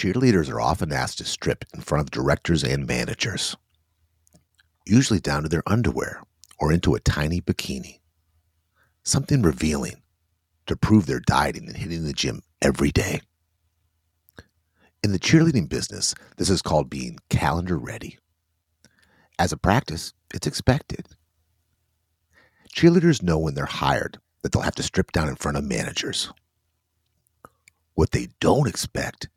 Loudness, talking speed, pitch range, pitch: -23 LUFS, 140 wpm, 80-95 Hz, 85 Hz